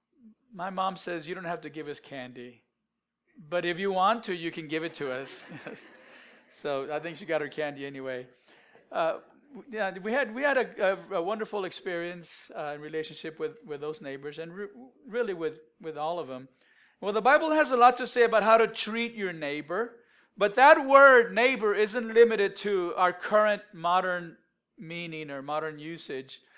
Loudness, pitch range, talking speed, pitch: -27 LUFS, 155-225 Hz, 185 wpm, 180 Hz